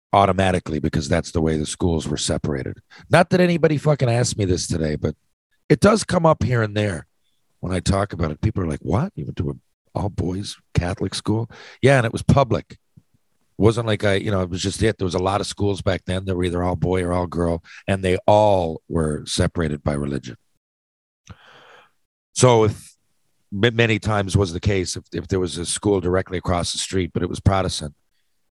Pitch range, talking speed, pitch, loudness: 85-105 Hz, 210 wpm, 95 Hz, -21 LUFS